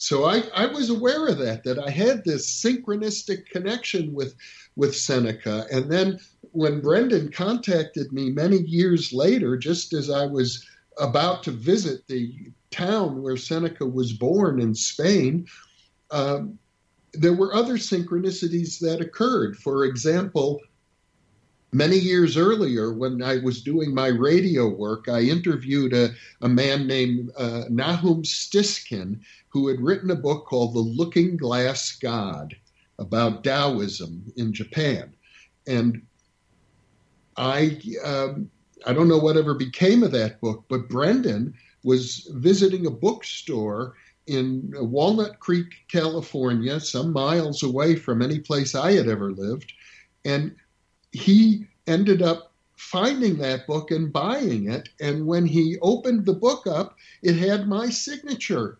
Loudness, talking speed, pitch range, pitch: -23 LUFS, 135 wpm, 125-180 Hz, 150 Hz